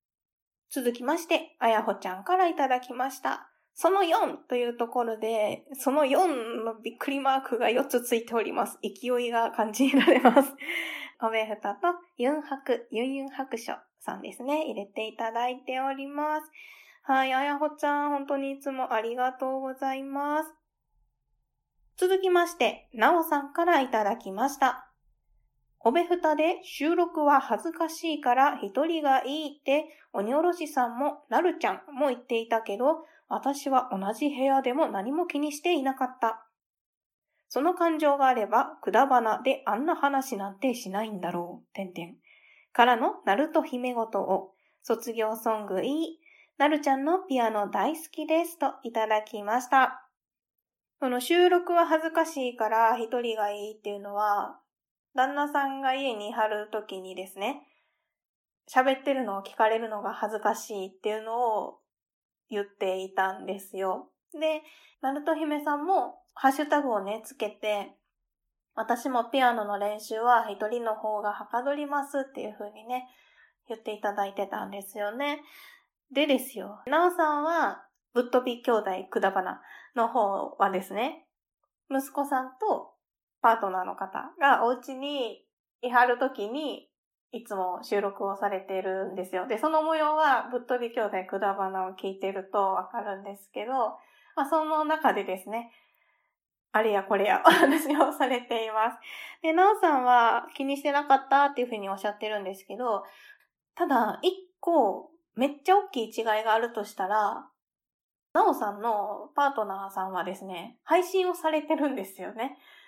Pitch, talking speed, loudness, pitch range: 255 Hz, 310 characters per minute, -28 LUFS, 215-295 Hz